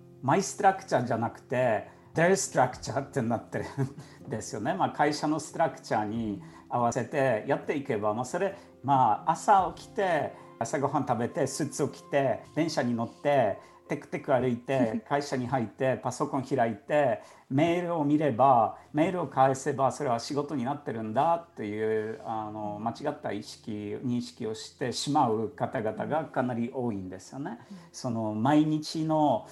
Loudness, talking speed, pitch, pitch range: -29 LUFS, 330 characters per minute, 135 Hz, 115-150 Hz